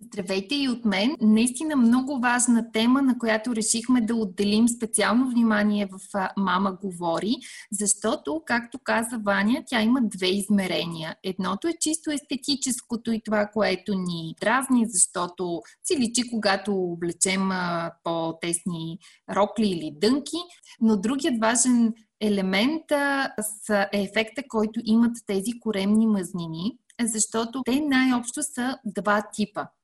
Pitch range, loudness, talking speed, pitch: 195-245 Hz, -24 LUFS, 125 wpm, 220 Hz